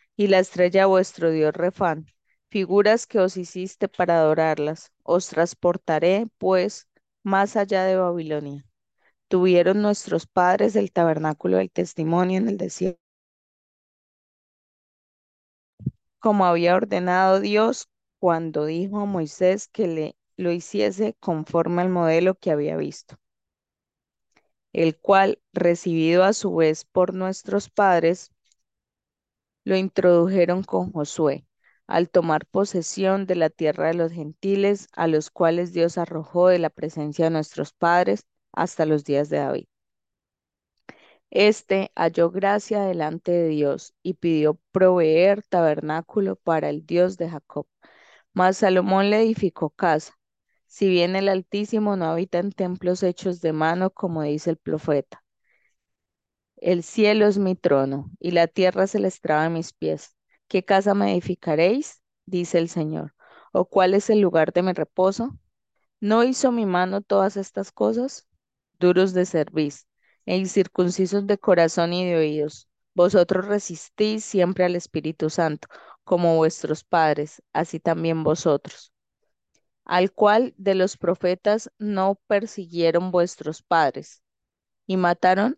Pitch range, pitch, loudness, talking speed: 160-195 Hz, 180 Hz, -22 LUFS, 135 wpm